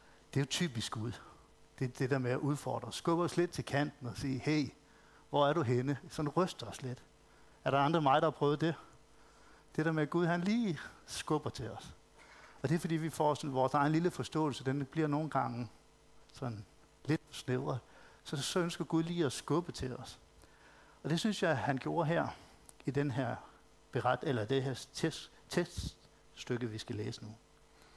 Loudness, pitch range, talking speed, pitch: -36 LUFS, 125-160 Hz, 200 wpm, 140 Hz